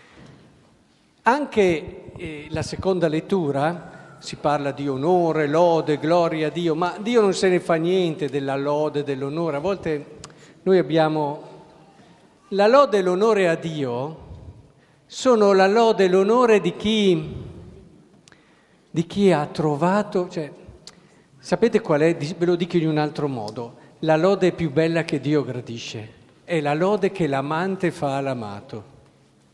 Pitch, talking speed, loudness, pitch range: 160 Hz, 140 wpm, -21 LUFS, 145-185 Hz